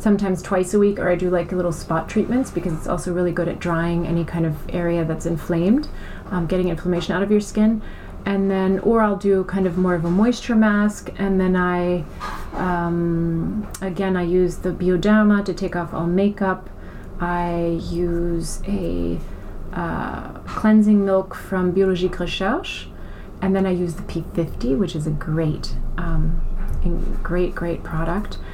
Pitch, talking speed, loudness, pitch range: 180 Hz, 170 wpm, -21 LUFS, 170-195 Hz